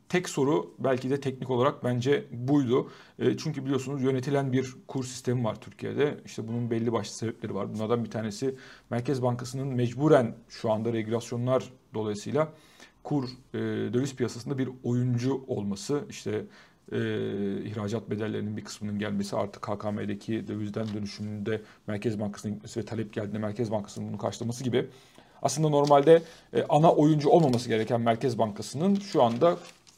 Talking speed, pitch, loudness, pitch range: 145 wpm, 120 Hz, -29 LUFS, 110-135 Hz